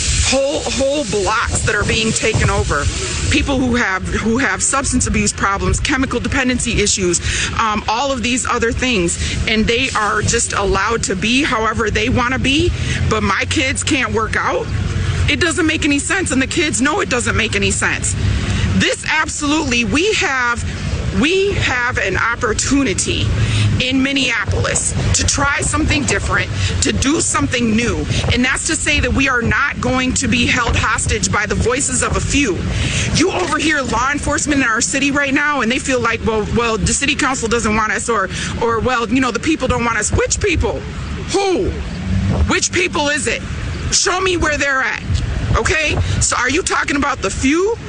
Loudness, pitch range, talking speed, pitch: -16 LUFS, 185-295 Hz, 180 wpm, 255 Hz